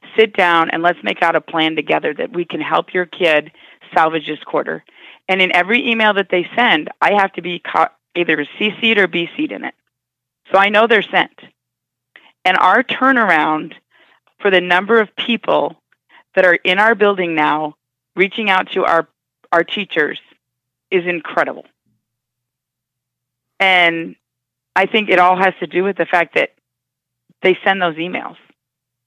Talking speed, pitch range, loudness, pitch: 165 wpm, 150-200 Hz, -15 LUFS, 175 Hz